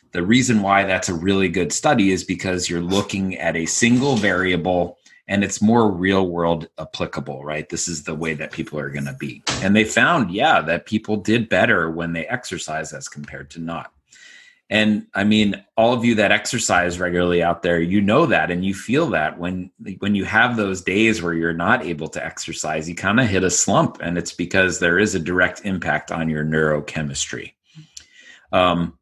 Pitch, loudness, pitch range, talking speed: 90 Hz, -19 LUFS, 85-100 Hz, 200 wpm